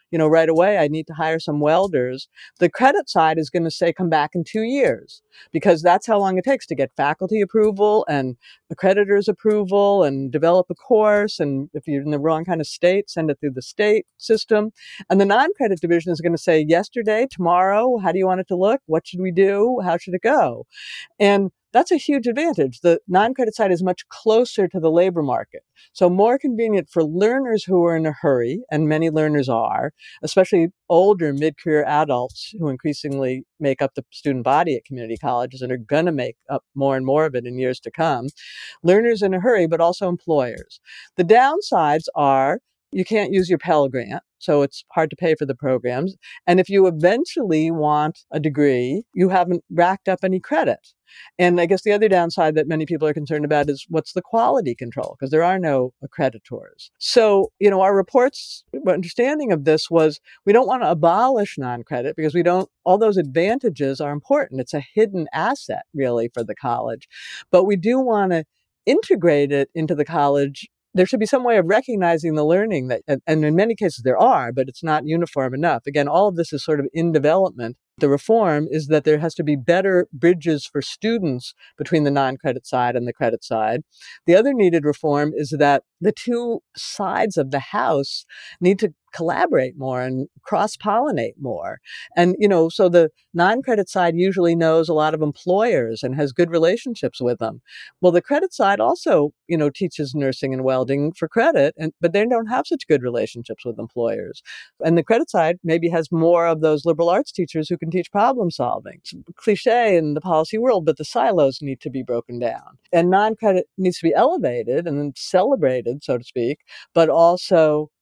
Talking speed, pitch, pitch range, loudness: 200 wpm, 165 Hz, 145-195 Hz, -19 LUFS